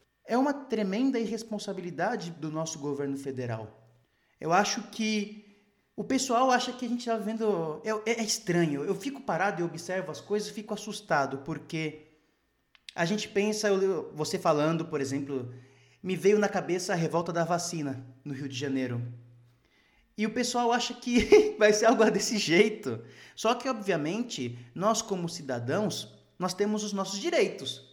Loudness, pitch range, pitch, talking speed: -29 LUFS, 145-220 Hz, 190 Hz, 160 wpm